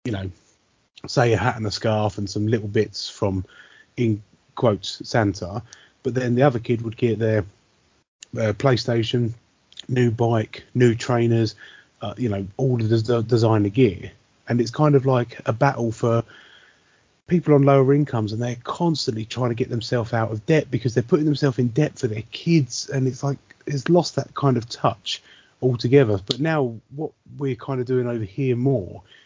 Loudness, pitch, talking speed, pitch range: -22 LUFS, 120 Hz, 185 wpm, 110-135 Hz